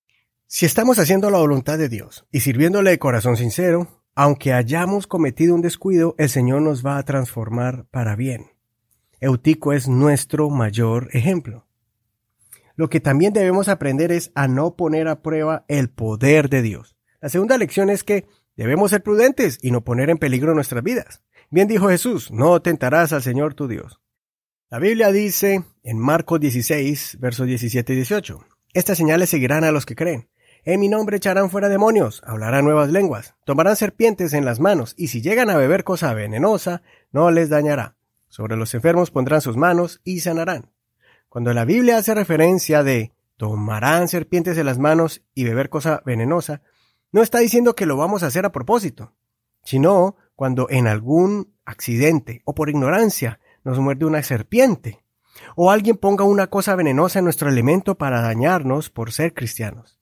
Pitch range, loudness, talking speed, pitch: 125-180 Hz, -18 LUFS, 170 wpm, 150 Hz